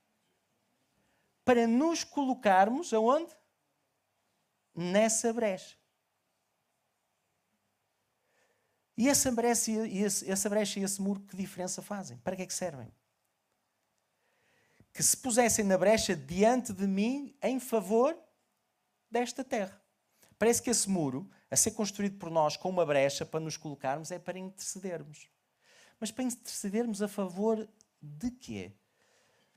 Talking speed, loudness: 125 wpm, -30 LUFS